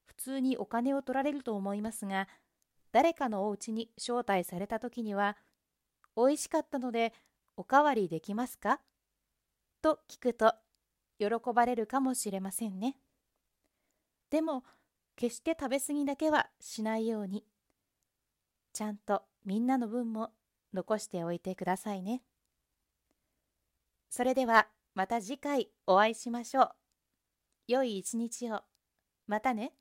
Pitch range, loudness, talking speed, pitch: 205-260 Hz, -33 LUFS, 260 characters per minute, 225 Hz